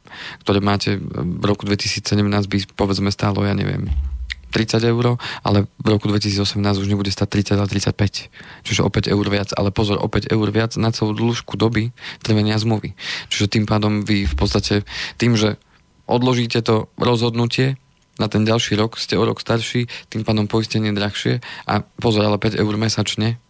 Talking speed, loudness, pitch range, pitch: 170 wpm, -19 LUFS, 100-115 Hz, 105 Hz